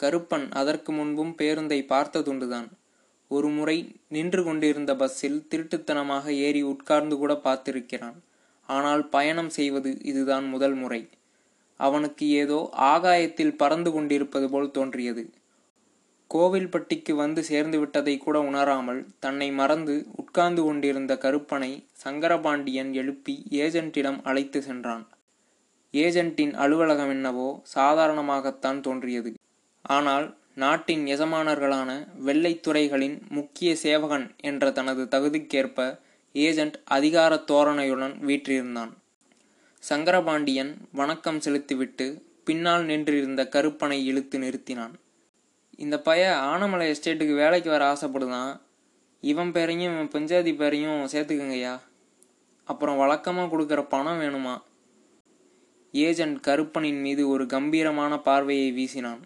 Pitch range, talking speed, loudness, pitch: 135-160 Hz, 95 wpm, -26 LUFS, 145 Hz